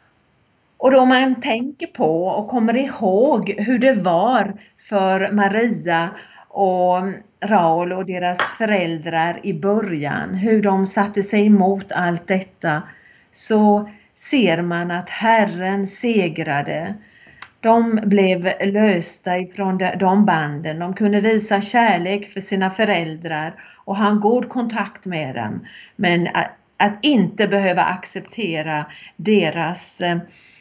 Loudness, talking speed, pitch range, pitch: -19 LUFS, 120 wpm, 180-215 Hz, 195 Hz